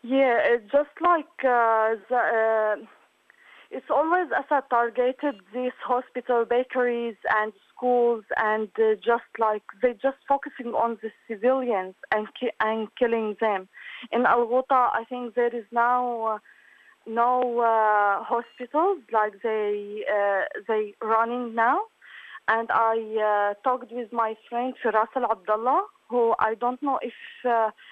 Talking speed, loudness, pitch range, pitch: 140 wpm, -25 LUFS, 220-250 Hz, 235 Hz